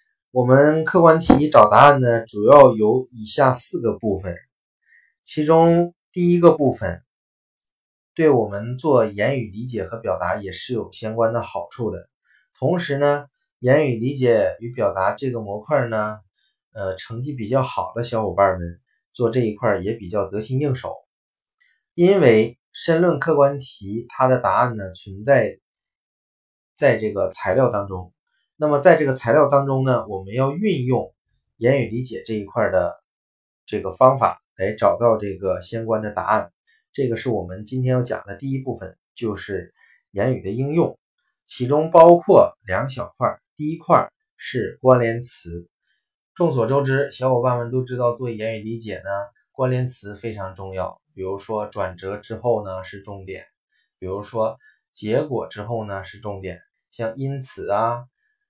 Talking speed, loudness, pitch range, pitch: 230 characters per minute, -19 LUFS, 105-135 Hz, 120 Hz